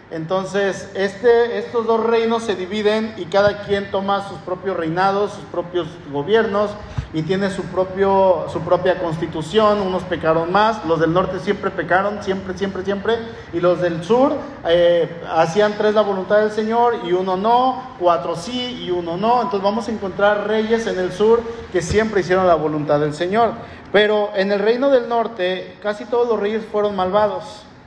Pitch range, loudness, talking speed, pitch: 180-215 Hz, -19 LUFS, 175 wpm, 200 Hz